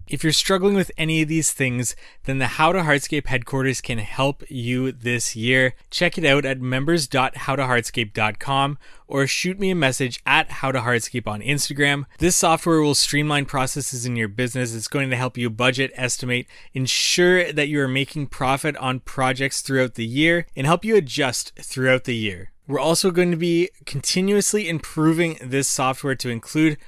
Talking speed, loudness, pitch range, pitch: 170 wpm, -21 LUFS, 125-155 Hz, 135 Hz